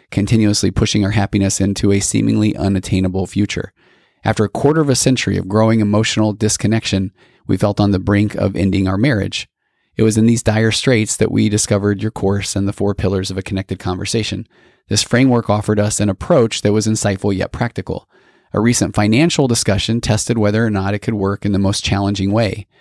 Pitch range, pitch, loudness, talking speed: 100-110 Hz, 105 Hz, -16 LUFS, 195 wpm